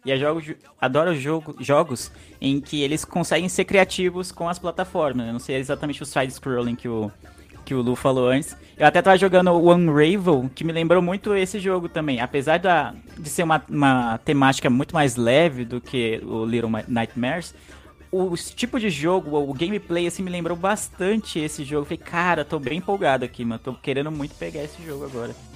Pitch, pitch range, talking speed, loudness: 150 Hz, 130-175 Hz, 190 wpm, -22 LUFS